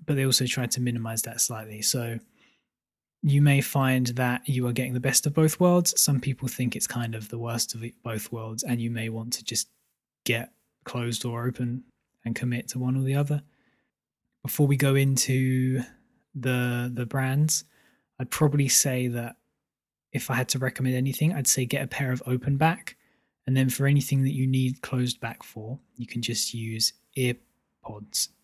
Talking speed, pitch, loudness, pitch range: 190 wpm, 125 Hz, -26 LUFS, 120-135 Hz